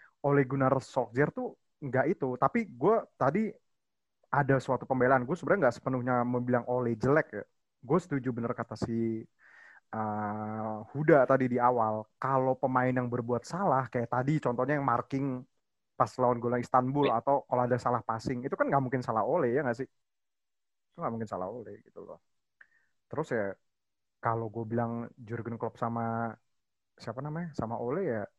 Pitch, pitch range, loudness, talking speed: 125 Hz, 115-135 Hz, -30 LUFS, 165 wpm